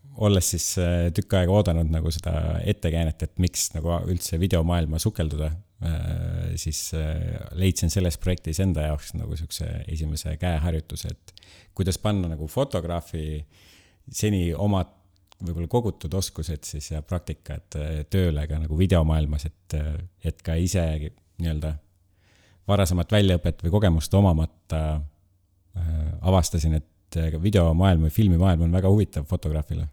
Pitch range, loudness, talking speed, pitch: 80-95 Hz, -25 LUFS, 120 wpm, 85 Hz